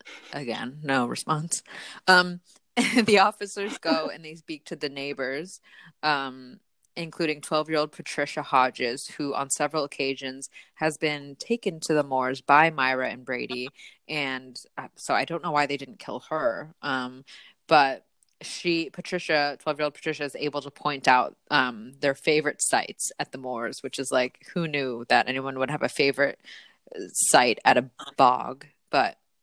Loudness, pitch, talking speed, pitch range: -25 LUFS, 145 Hz, 165 wpm, 135-160 Hz